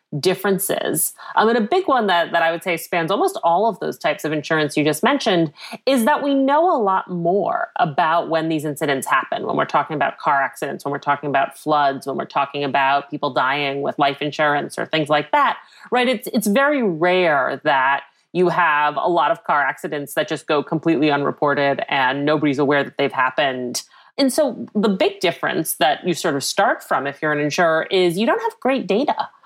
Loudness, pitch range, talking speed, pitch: -19 LUFS, 145-215 Hz, 210 wpm, 165 Hz